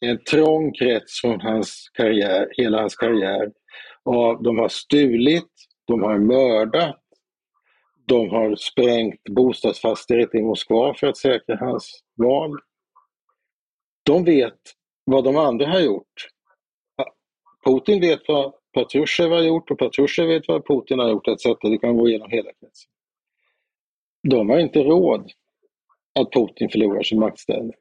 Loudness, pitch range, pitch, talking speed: -20 LUFS, 115-150 Hz, 125 Hz, 135 wpm